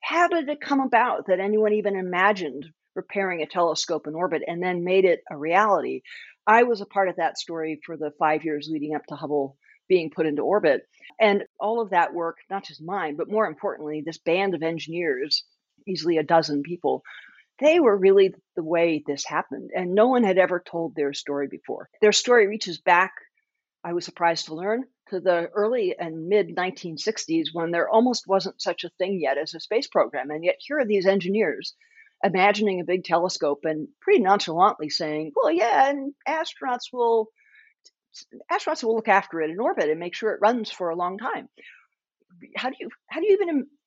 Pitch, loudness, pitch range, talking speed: 185 Hz, -24 LUFS, 165-225 Hz, 195 wpm